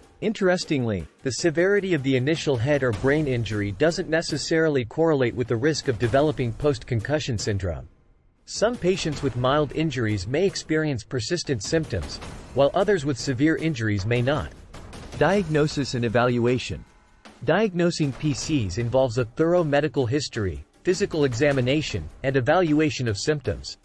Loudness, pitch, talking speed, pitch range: -24 LUFS, 140 Hz, 135 wpm, 120-155 Hz